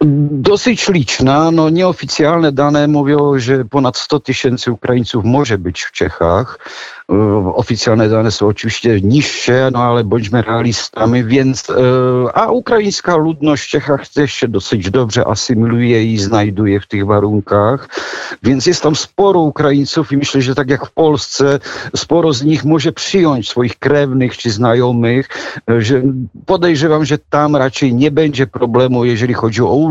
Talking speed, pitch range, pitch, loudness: 150 wpm, 120-150 Hz, 130 Hz, -13 LUFS